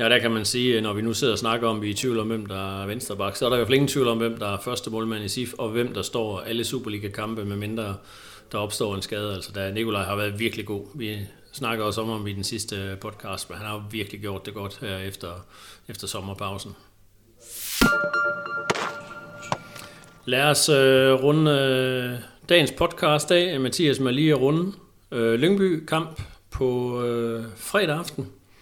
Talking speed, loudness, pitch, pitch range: 195 wpm, -24 LUFS, 115 Hz, 105-135 Hz